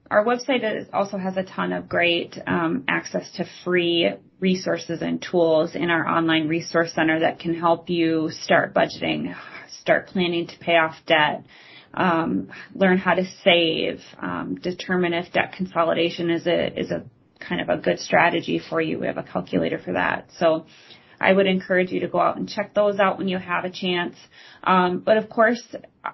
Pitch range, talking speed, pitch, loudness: 165-190 Hz, 185 wpm, 175 Hz, -22 LUFS